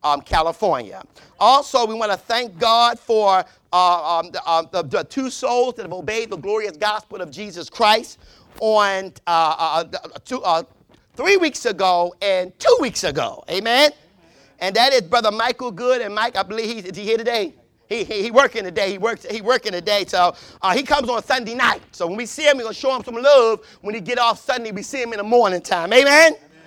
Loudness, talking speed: -19 LUFS, 215 wpm